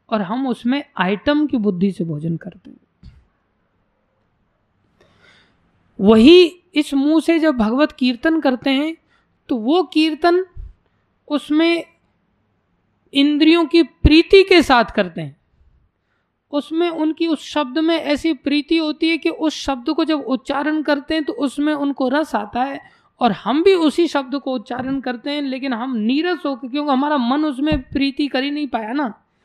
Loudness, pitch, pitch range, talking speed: -17 LUFS, 290 Hz, 255-315 Hz, 155 wpm